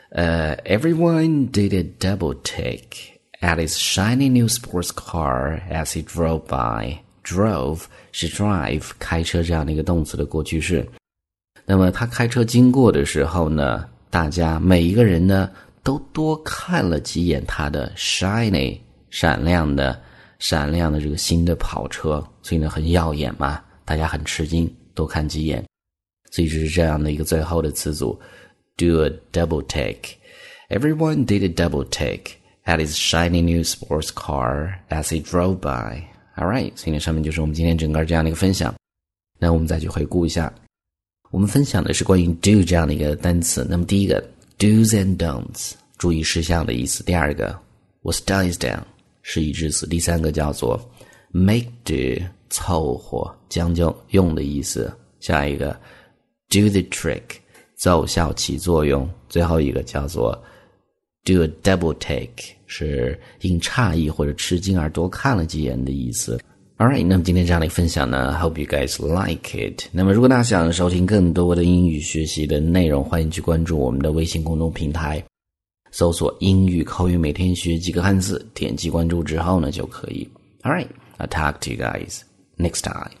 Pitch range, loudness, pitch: 75-95 Hz, -20 LUFS, 85 Hz